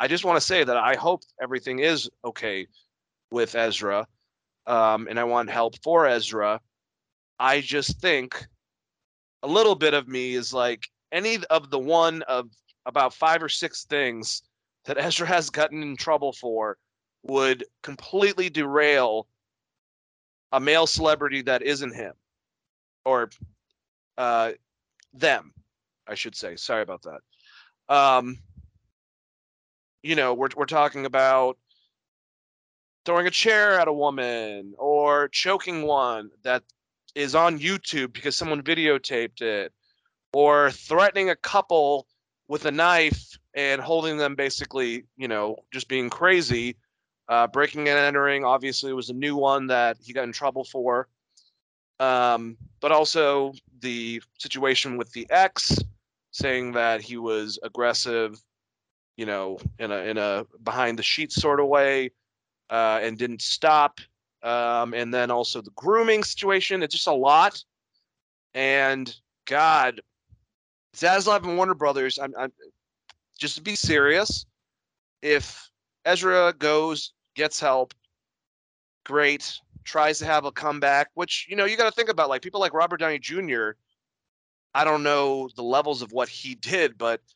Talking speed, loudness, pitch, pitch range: 140 wpm, -23 LUFS, 135 Hz, 120-150 Hz